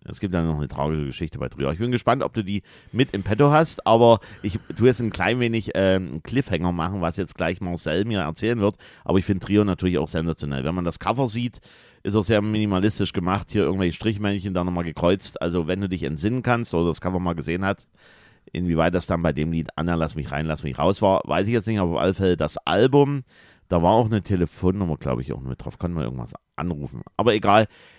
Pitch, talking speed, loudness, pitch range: 95 Hz, 240 wpm, -23 LUFS, 80-105 Hz